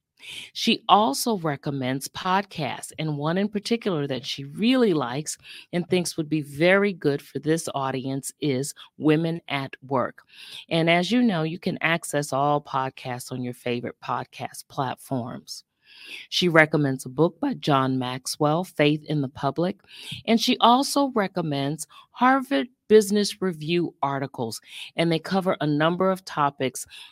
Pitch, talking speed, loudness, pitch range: 160 Hz, 145 wpm, -24 LUFS, 140-190 Hz